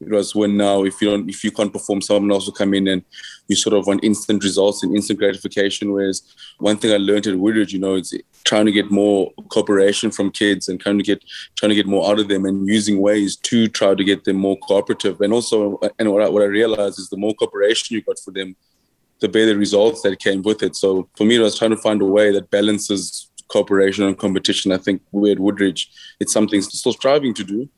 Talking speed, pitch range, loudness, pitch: 245 wpm, 100-105 Hz, -18 LUFS, 100 Hz